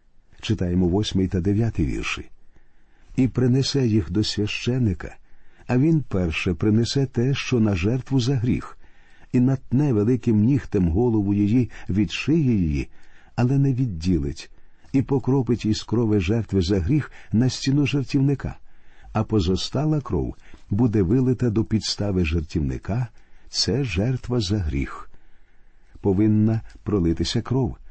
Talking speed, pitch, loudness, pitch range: 120 wpm, 110 Hz, -23 LUFS, 95-130 Hz